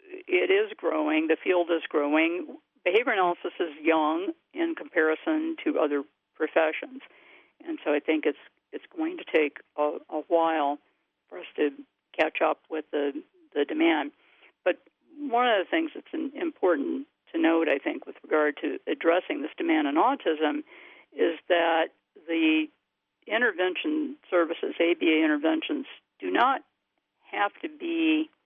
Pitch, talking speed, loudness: 280 Hz, 145 wpm, -27 LUFS